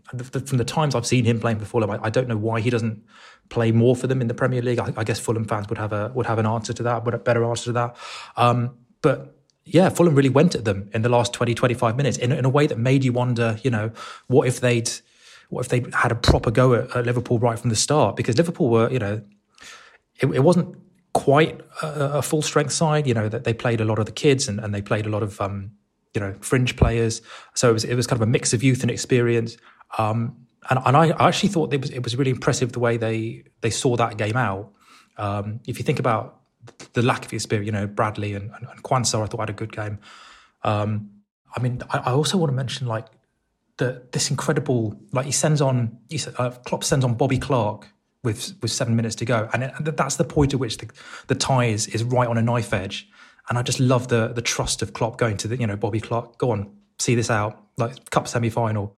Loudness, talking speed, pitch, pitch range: -22 LUFS, 250 wpm, 120 Hz, 110-130 Hz